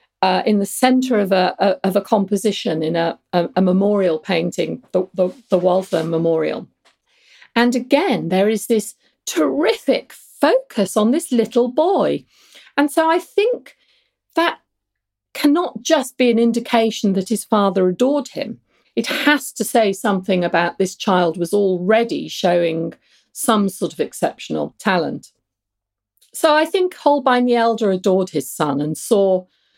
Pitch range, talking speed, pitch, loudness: 180-255 Hz, 145 wpm, 205 Hz, -18 LUFS